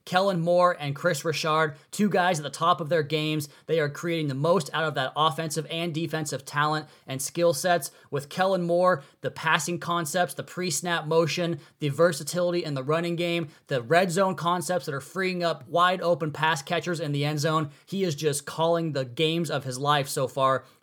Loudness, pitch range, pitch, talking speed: -26 LUFS, 150-175 Hz, 165 Hz, 205 wpm